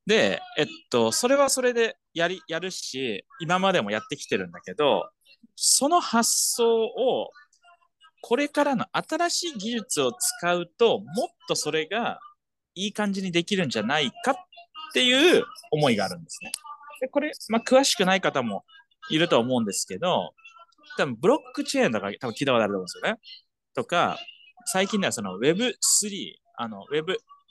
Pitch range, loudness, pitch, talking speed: 190-320 Hz, -24 LUFS, 250 Hz, 320 characters per minute